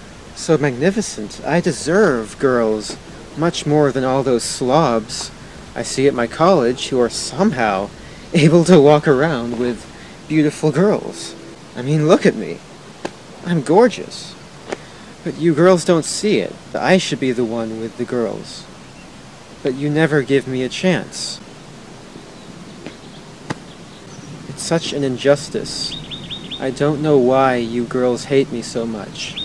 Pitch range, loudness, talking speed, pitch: 120-160 Hz, -17 LUFS, 140 wpm, 140 Hz